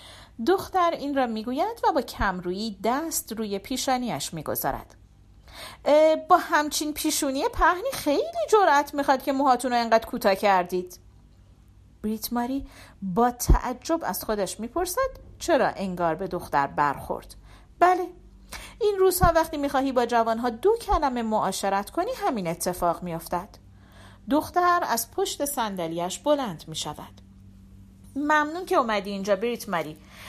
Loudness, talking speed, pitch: -25 LUFS, 120 wpm, 235 Hz